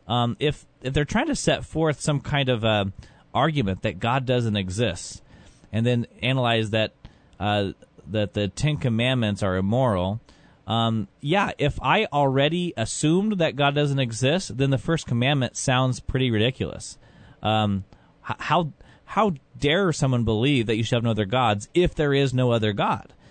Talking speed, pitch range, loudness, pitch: 165 wpm, 110-145 Hz, -24 LUFS, 125 Hz